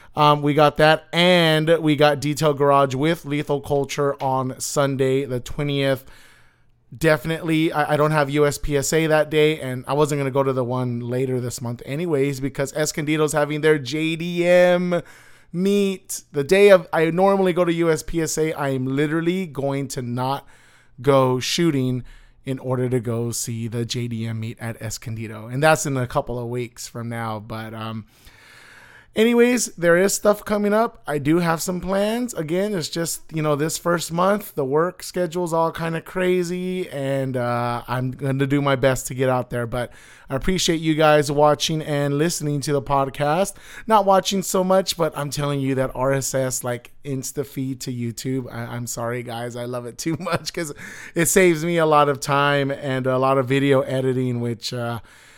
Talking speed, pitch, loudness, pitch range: 185 wpm, 145 Hz, -21 LUFS, 130-165 Hz